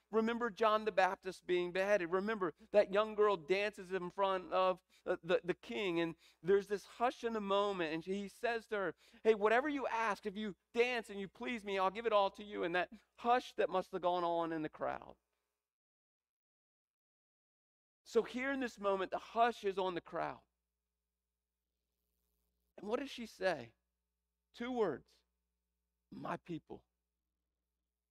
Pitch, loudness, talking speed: 185 Hz, -37 LUFS, 165 wpm